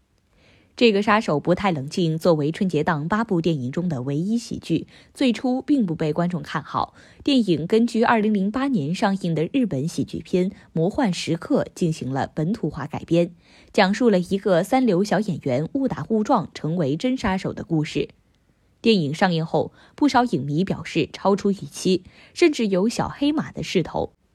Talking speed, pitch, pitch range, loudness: 265 characters per minute, 185 Hz, 160-220 Hz, -22 LUFS